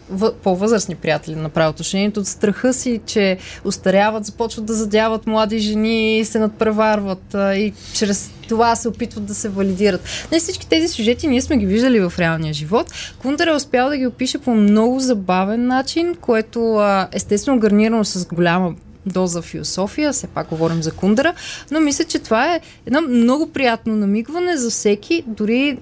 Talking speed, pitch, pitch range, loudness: 165 wpm, 220 Hz, 195-250 Hz, -18 LUFS